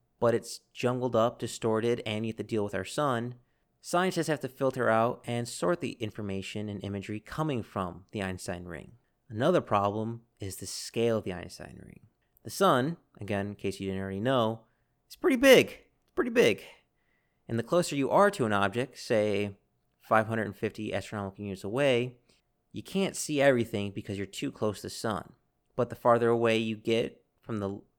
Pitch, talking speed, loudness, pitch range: 110 Hz, 180 wpm, -29 LUFS, 100-125 Hz